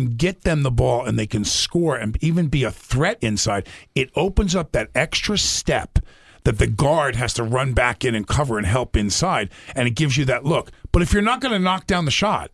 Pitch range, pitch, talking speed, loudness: 110-155 Hz, 125 Hz, 235 wpm, -20 LUFS